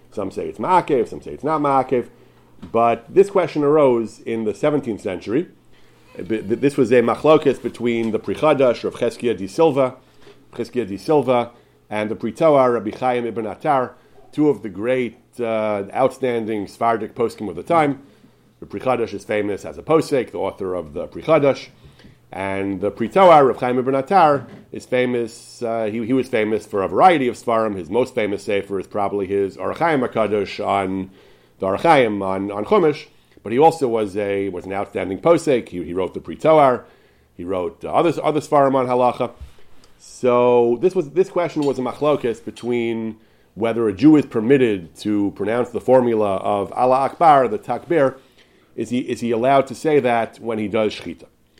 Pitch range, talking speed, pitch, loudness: 105-130 Hz, 180 wpm, 115 Hz, -19 LUFS